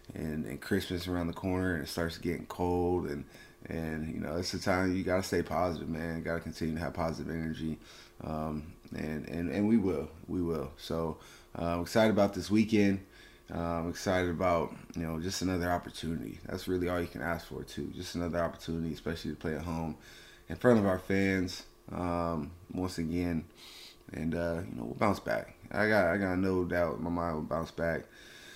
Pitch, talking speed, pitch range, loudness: 85 Hz, 205 wpm, 80-90 Hz, -33 LUFS